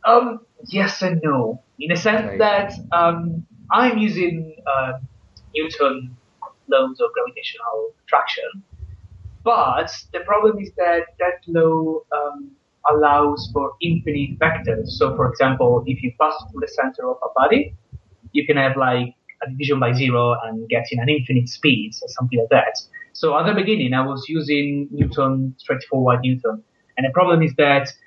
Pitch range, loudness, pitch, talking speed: 130-180 Hz, -19 LUFS, 150 Hz, 160 wpm